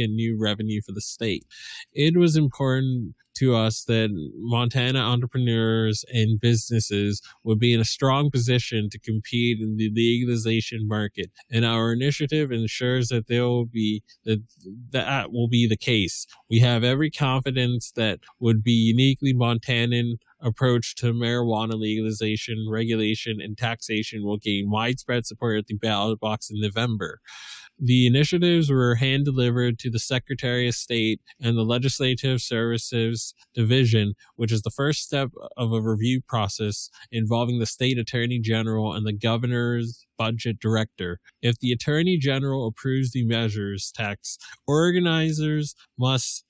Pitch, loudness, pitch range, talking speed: 115 Hz, -24 LUFS, 110-125 Hz, 145 wpm